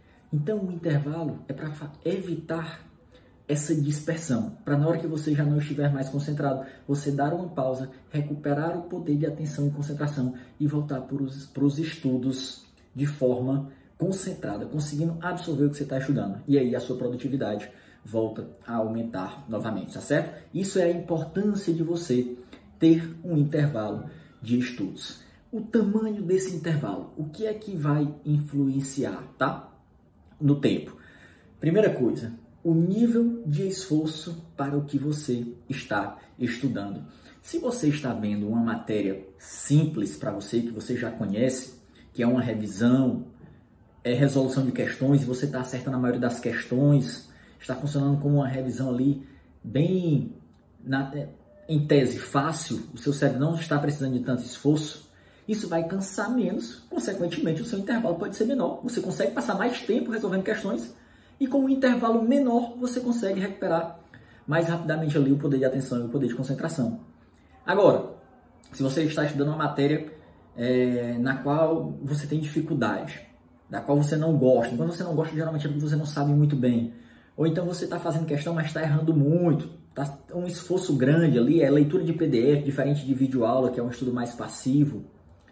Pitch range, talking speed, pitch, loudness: 130-165 Hz, 165 wpm, 145 Hz, -26 LUFS